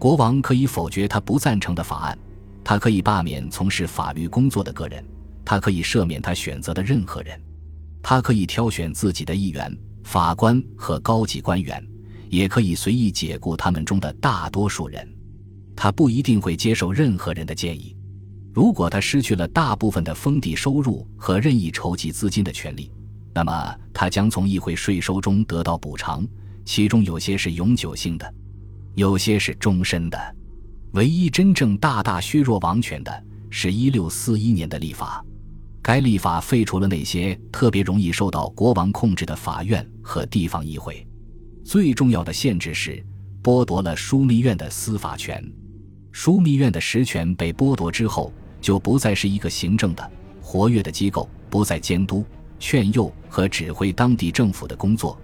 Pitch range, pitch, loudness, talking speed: 85-110 Hz, 100 Hz, -21 LUFS, 260 characters per minute